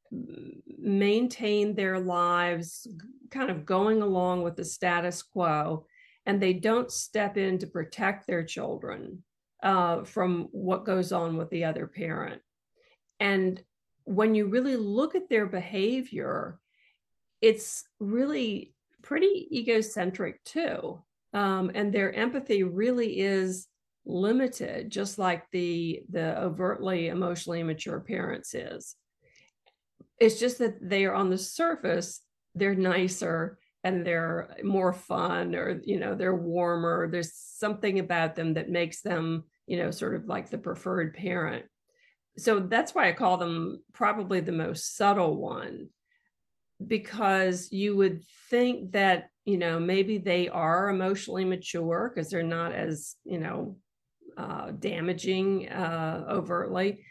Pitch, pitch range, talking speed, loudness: 190 Hz, 175-215 Hz, 130 wpm, -29 LUFS